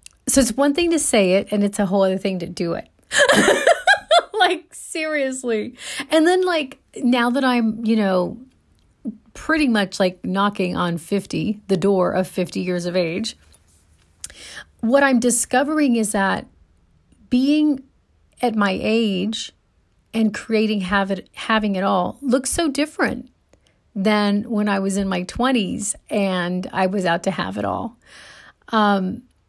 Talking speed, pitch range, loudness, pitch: 150 wpm, 190-260 Hz, -20 LUFS, 215 Hz